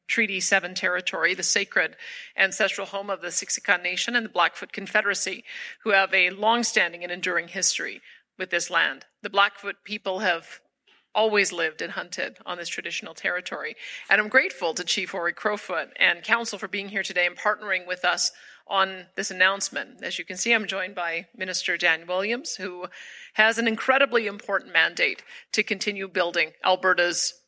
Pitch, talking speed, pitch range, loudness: 195 Hz, 170 wpm, 180-210 Hz, -24 LUFS